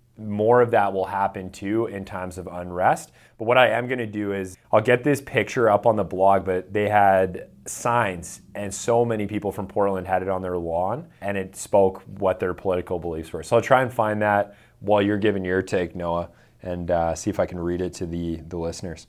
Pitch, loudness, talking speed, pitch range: 100 Hz, -23 LUFS, 230 wpm, 90-105 Hz